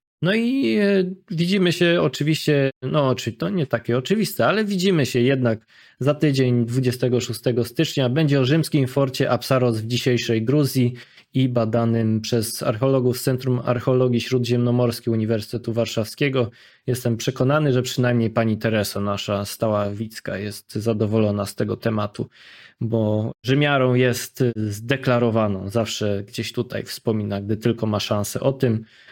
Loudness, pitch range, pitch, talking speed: -21 LUFS, 115-135 Hz, 120 Hz, 135 wpm